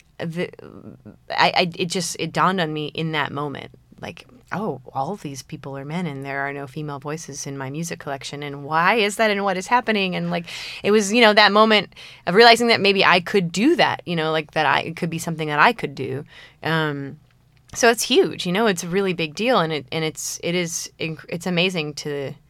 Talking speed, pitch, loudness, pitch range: 230 wpm, 165 Hz, -20 LUFS, 145-195 Hz